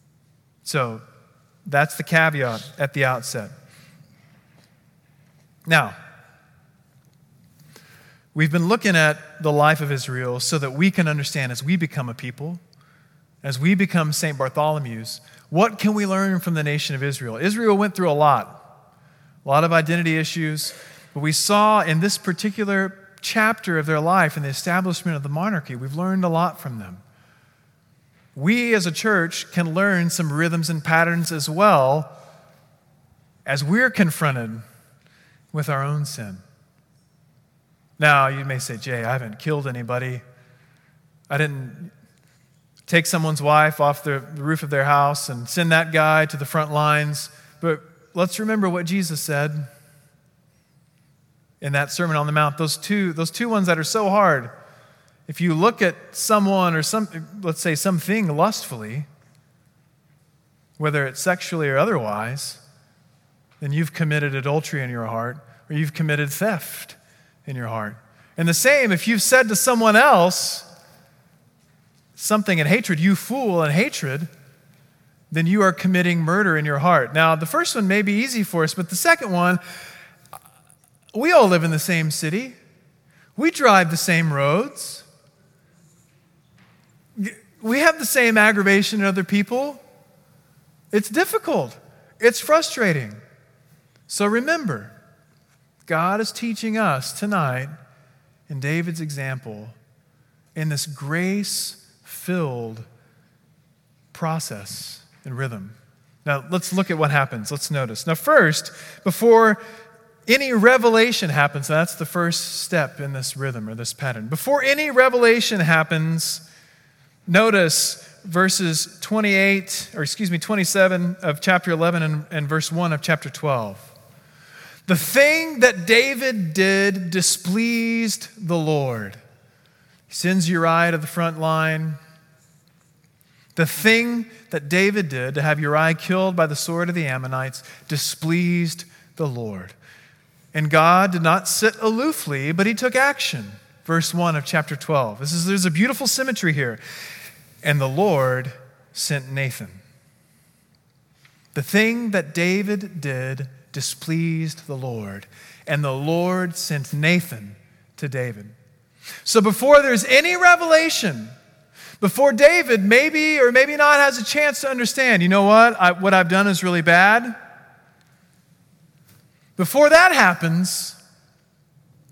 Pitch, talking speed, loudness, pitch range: 160 Hz, 140 wpm, -19 LUFS, 145-185 Hz